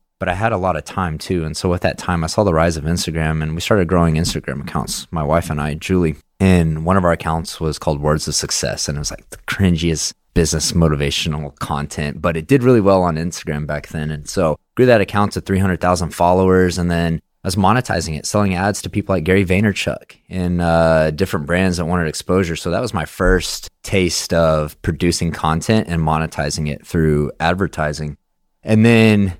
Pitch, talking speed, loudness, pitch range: 85 Hz, 210 wpm, -17 LUFS, 80-95 Hz